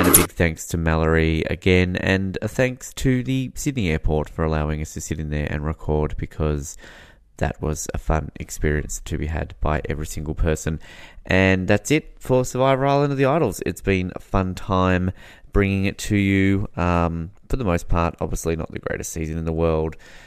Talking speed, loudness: 200 wpm, -22 LUFS